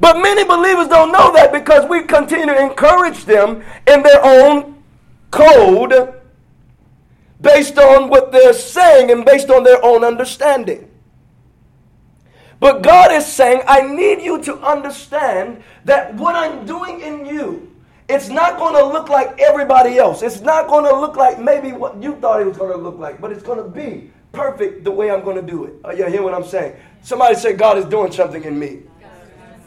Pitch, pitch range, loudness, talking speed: 280 Hz, 235-315 Hz, -11 LUFS, 180 wpm